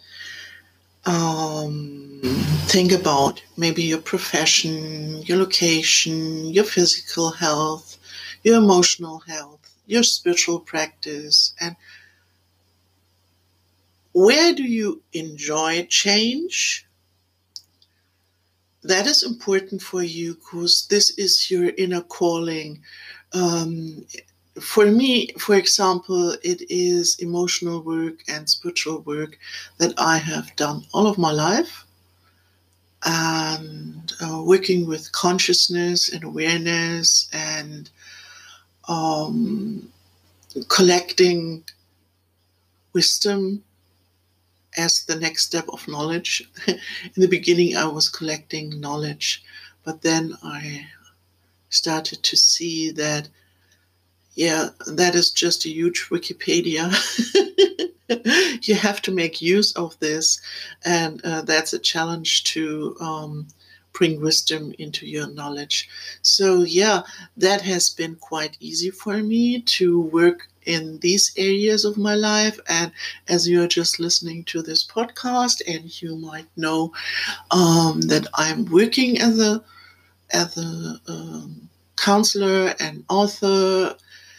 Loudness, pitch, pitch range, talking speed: -19 LUFS, 165 Hz, 155-190 Hz, 110 wpm